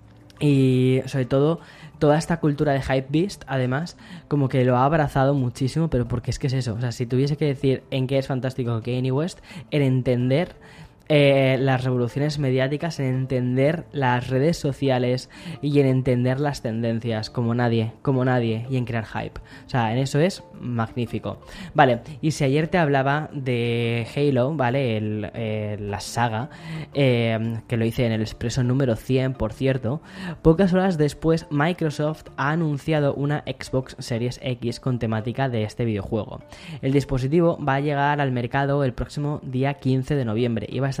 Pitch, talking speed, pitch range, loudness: 130 Hz, 180 wpm, 120-145 Hz, -23 LUFS